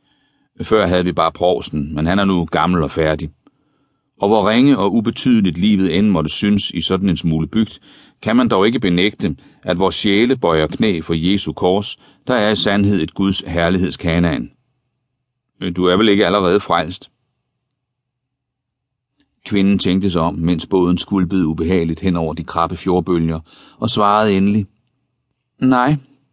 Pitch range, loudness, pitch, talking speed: 85-110 Hz, -16 LUFS, 95 Hz, 155 wpm